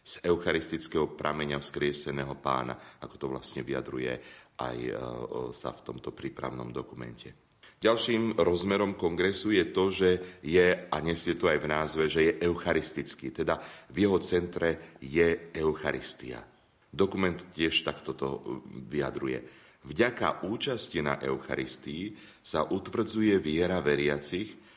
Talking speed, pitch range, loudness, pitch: 120 wpm, 65-90 Hz, -30 LUFS, 75 Hz